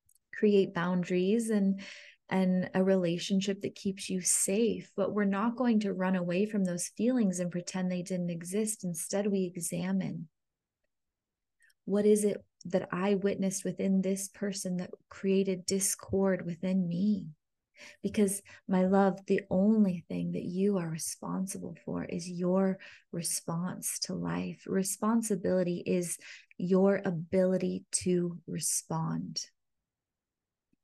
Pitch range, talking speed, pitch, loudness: 180-200 Hz, 125 wpm, 190 Hz, -31 LUFS